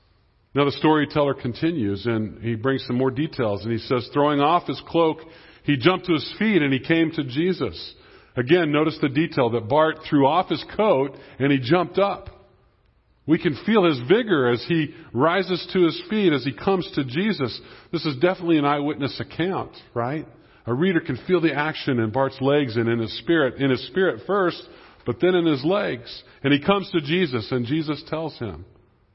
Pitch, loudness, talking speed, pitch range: 145 Hz, -22 LUFS, 195 wpm, 125-165 Hz